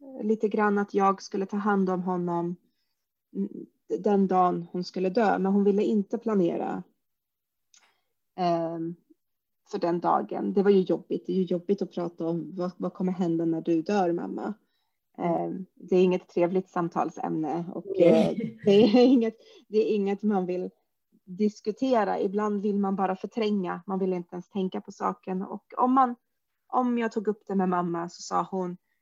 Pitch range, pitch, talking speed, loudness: 180-215 Hz, 195 Hz, 175 wpm, -27 LUFS